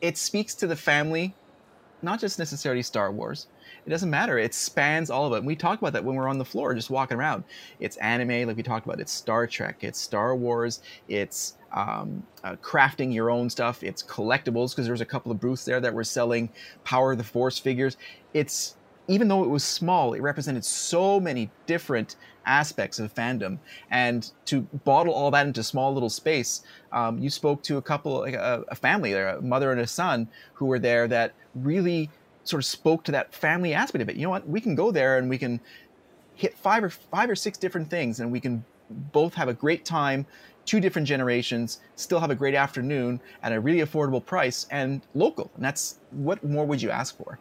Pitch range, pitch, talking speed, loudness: 120-160 Hz, 135 Hz, 215 wpm, -26 LUFS